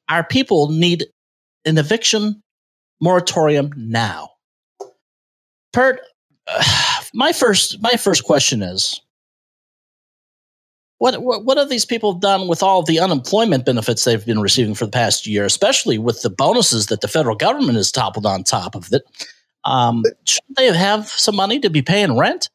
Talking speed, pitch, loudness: 155 wpm, 170 Hz, -16 LUFS